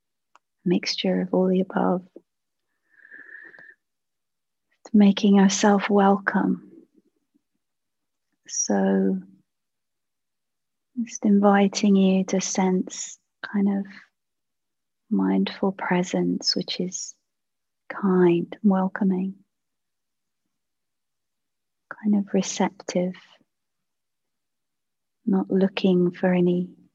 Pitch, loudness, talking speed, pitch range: 195 Hz, -23 LUFS, 65 wpm, 180-205 Hz